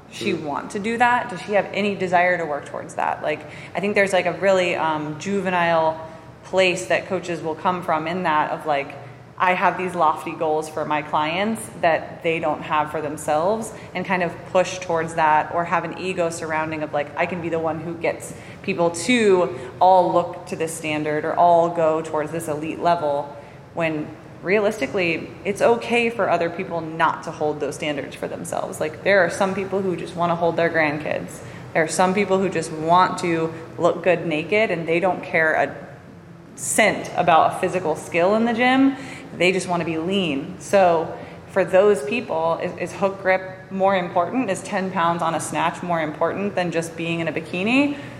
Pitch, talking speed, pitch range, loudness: 170 Hz, 200 wpm, 160-185 Hz, -21 LUFS